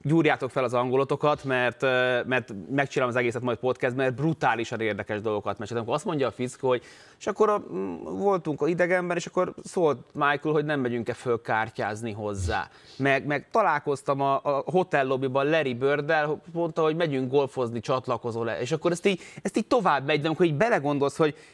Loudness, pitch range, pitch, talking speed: -26 LUFS, 120-155 Hz, 135 Hz, 180 wpm